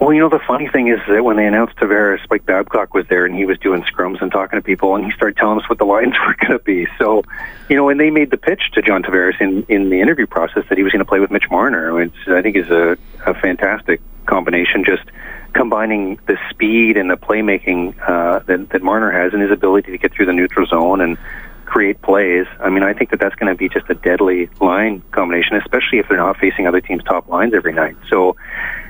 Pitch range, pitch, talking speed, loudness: 90-115 Hz, 100 Hz, 250 wpm, -15 LUFS